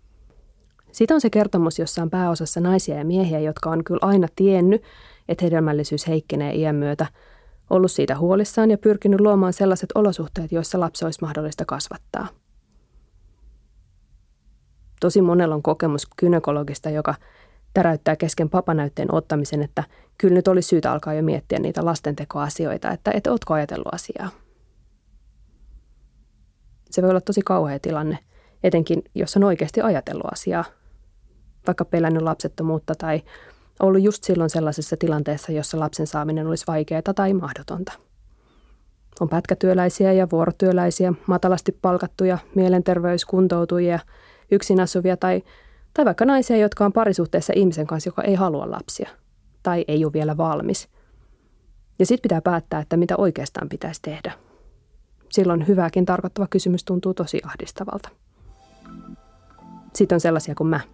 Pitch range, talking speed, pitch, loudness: 155-190 Hz, 130 wpm, 175 Hz, -21 LUFS